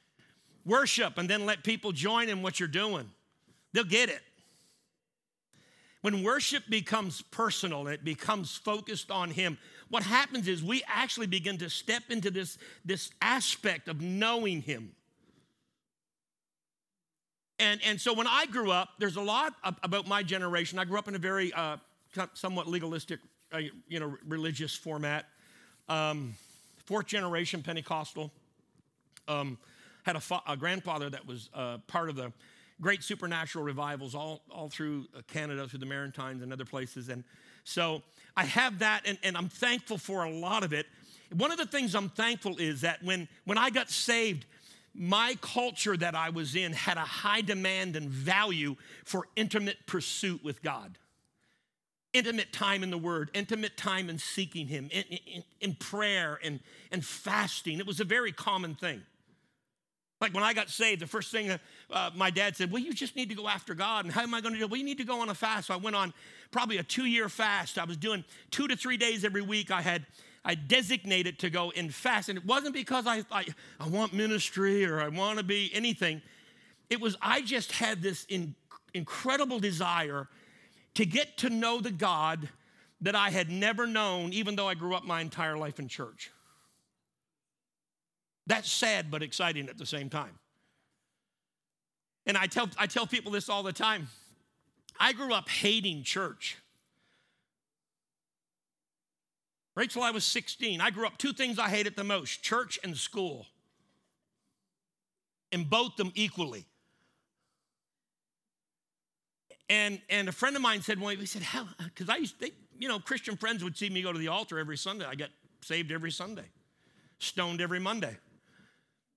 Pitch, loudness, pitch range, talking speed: 190 Hz, -31 LUFS, 160-215 Hz, 175 wpm